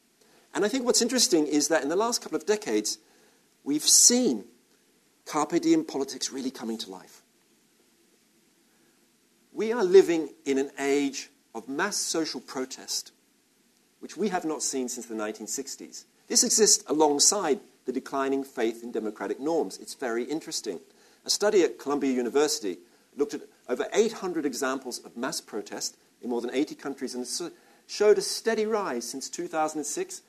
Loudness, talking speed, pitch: -26 LUFS, 155 wpm, 150 Hz